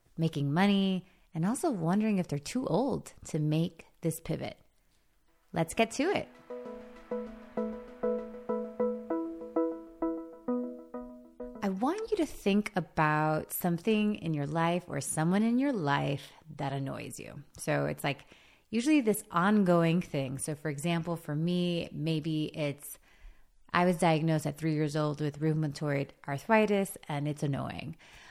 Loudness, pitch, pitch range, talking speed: -31 LUFS, 165 Hz, 150-210 Hz, 130 wpm